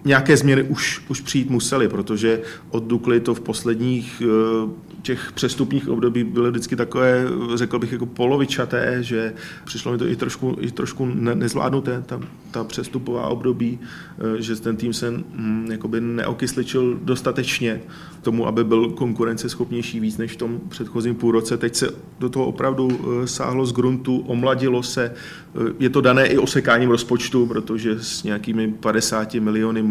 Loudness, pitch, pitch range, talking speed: -21 LUFS, 120 Hz, 115-130 Hz, 145 wpm